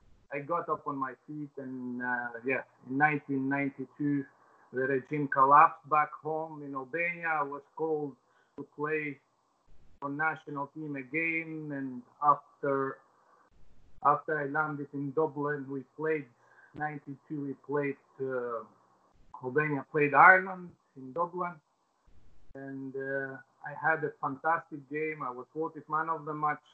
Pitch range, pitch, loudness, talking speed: 135-155 Hz, 145 Hz, -31 LUFS, 130 wpm